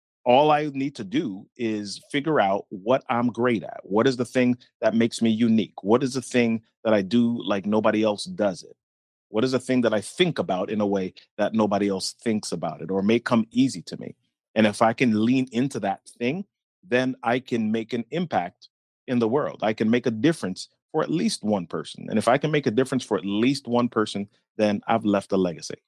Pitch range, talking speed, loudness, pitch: 105-125 Hz, 230 wpm, -24 LUFS, 115 Hz